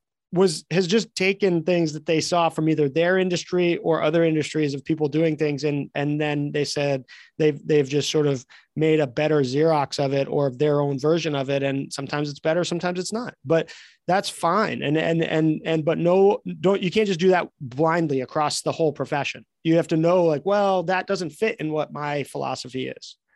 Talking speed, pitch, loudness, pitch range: 210 wpm, 160 Hz, -23 LUFS, 145-175 Hz